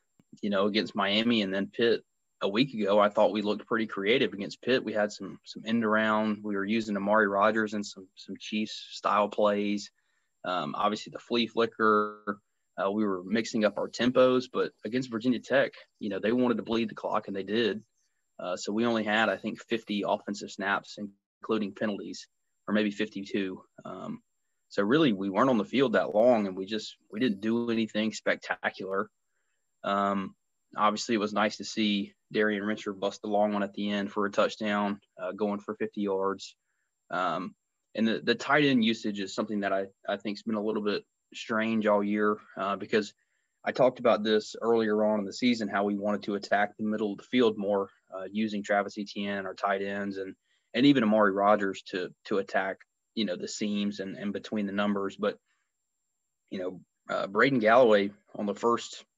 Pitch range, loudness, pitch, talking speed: 100-110 Hz, -29 LUFS, 105 Hz, 200 wpm